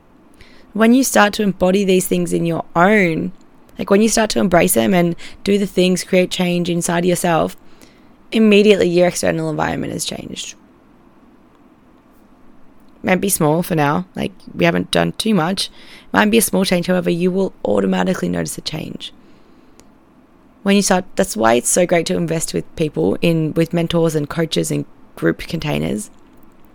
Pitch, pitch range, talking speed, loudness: 180 Hz, 160-200 Hz, 170 wpm, -16 LUFS